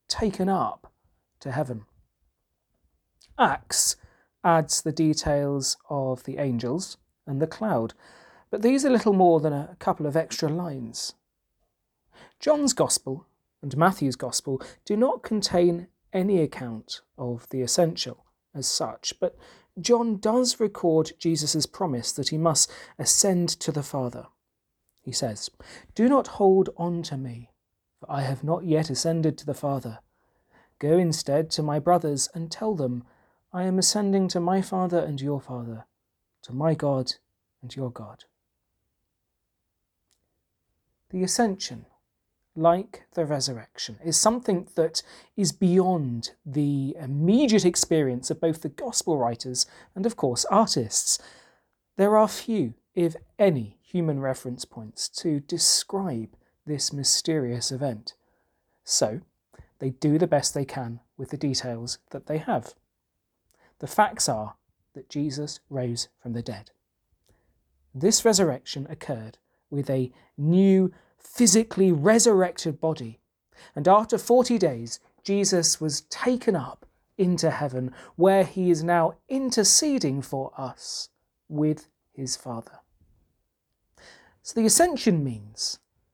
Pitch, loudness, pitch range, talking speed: 155 Hz, -25 LUFS, 130-185 Hz, 125 wpm